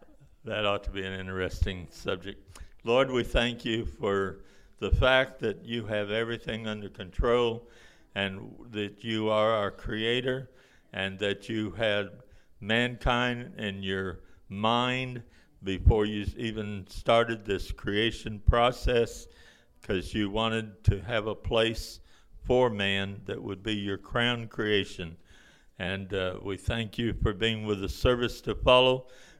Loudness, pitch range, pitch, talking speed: -29 LUFS, 95-115 Hz, 105 Hz, 140 wpm